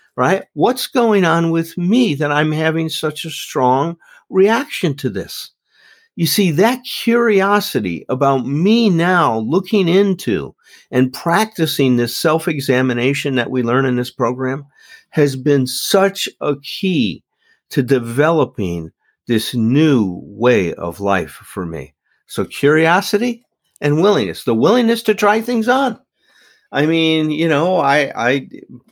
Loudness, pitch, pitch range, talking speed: -16 LUFS, 155 Hz, 130-200 Hz, 135 wpm